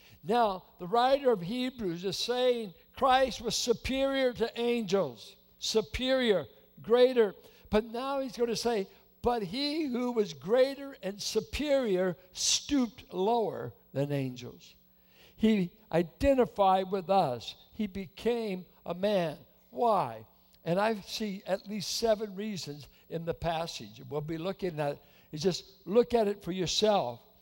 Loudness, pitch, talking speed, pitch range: -30 LUFS, 205 Hz, 135 wpm, 175-235 Hz